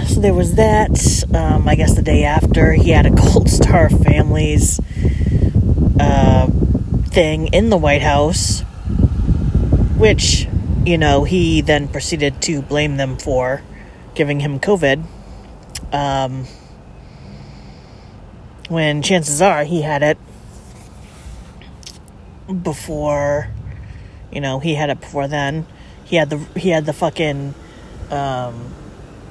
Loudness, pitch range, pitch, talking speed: -15 LUFS, 95-150 Hz, 140 Hz, 120 wpm